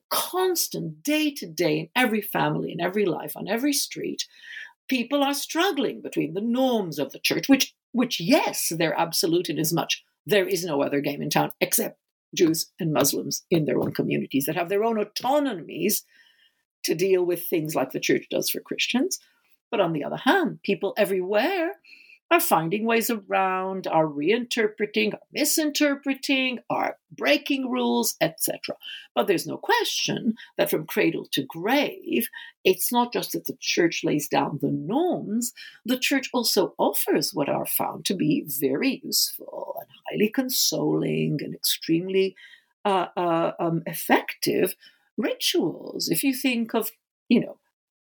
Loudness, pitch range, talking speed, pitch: -24 LUFS, 190-300 Hz, 155 wpm, 240 Hz